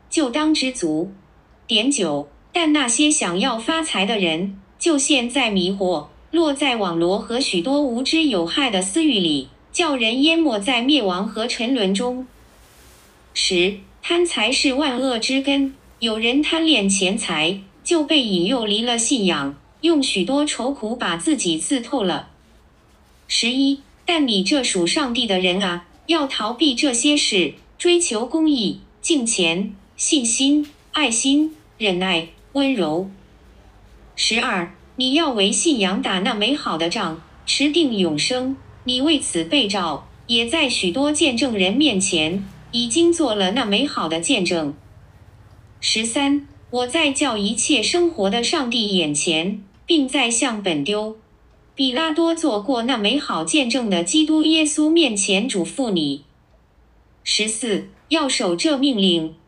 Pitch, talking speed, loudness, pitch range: 235 Hz, 200 characters per minute, -19 LUFS, 185-290 Hz